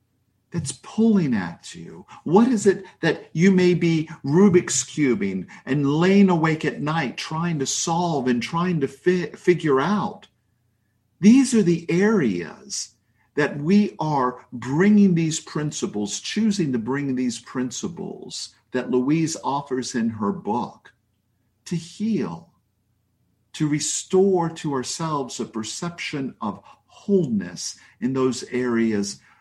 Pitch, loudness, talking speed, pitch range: 150 Hz, -22 LUFS, 125 wpm, 125-180 Hz